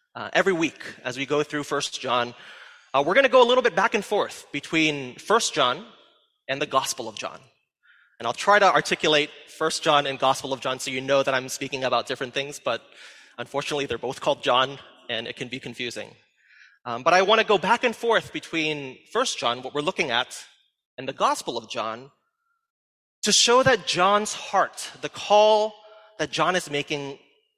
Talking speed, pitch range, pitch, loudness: 200 wpm, 135-215 Hz, 155 Hz, -23 LUFS